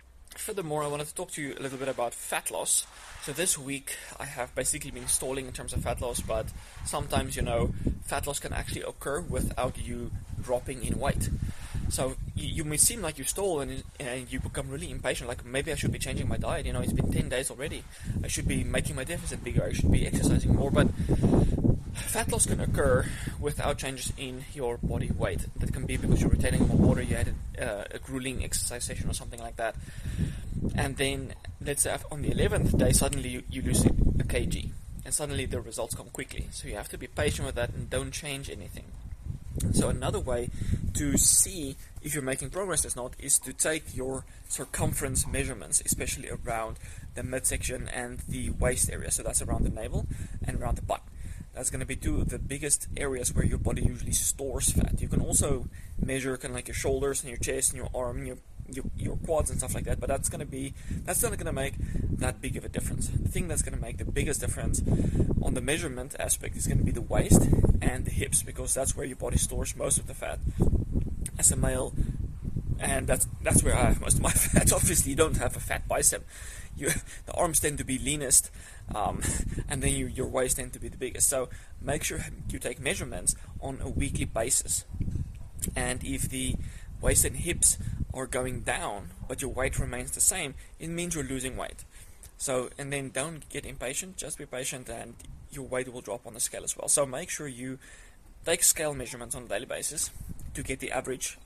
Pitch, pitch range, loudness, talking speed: 130 Hz, 115-135 Hz, -29 LUFS, 215 wpm